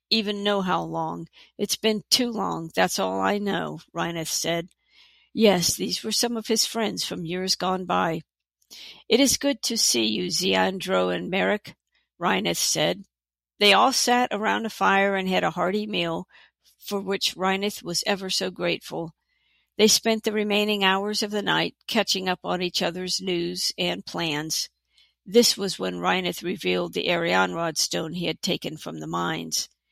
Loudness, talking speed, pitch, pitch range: -24 LUFS, 170 wpm, 185 Hz, 160-210 Hz